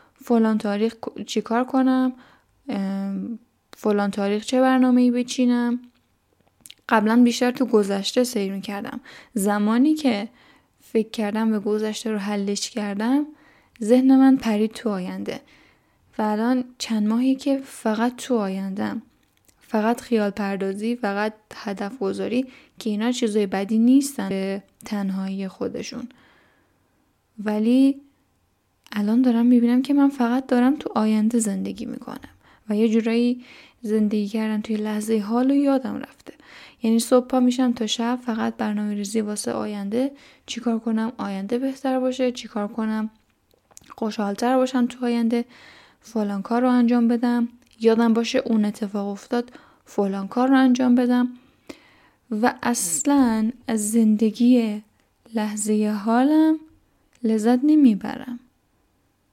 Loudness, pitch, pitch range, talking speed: -22 LUFS, 230 Hz, 210-250 Hz, 125 wpm